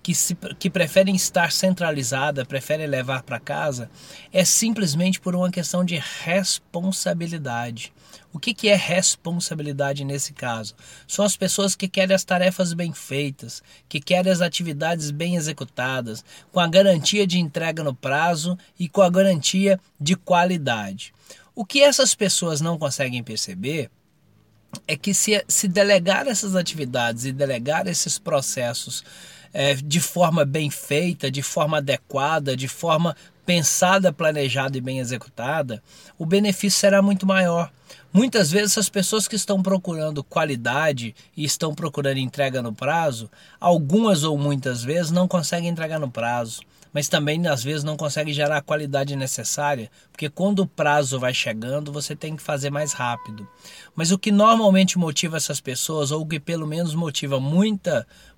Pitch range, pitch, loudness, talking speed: 140-185 Hz, 160 Hz, -21 LUFS, 150 wpm